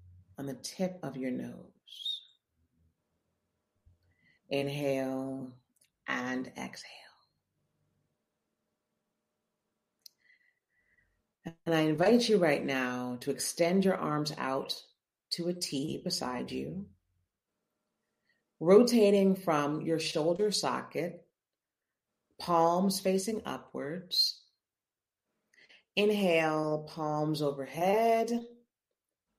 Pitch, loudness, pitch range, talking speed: 150 Hz, -31 LUFS, 125-185 Hz, 75 wpm